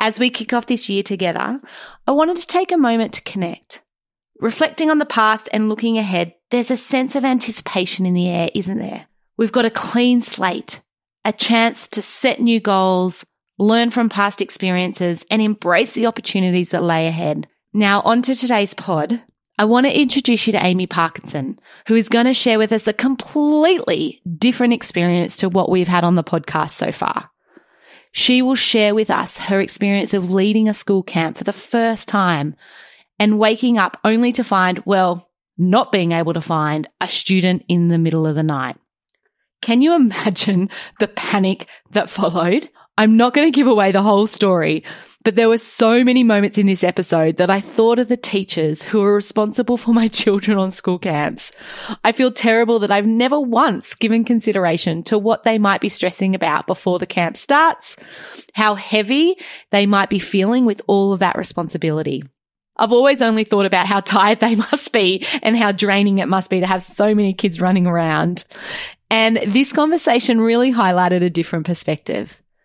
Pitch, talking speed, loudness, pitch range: 210 Hz, 185 wpm, -17 LUFS, 185-235 Hz